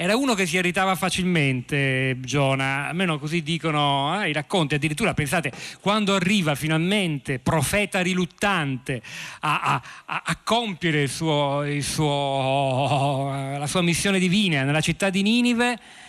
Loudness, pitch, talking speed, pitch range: -23 LUFS, 160 Hz, 135 wpm, 140-190 Hz